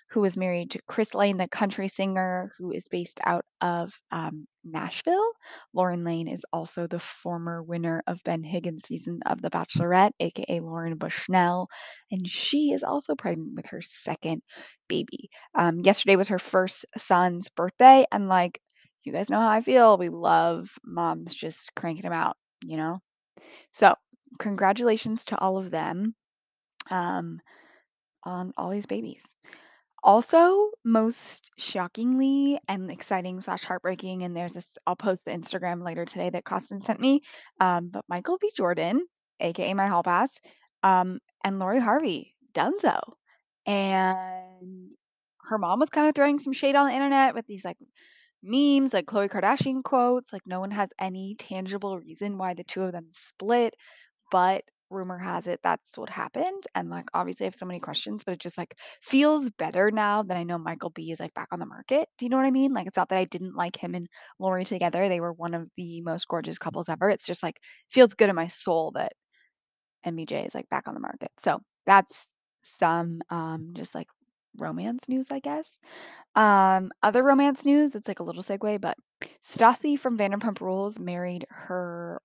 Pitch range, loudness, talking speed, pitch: 175-245 Hz, -26 LUFS, 180 wpm, 190 Hz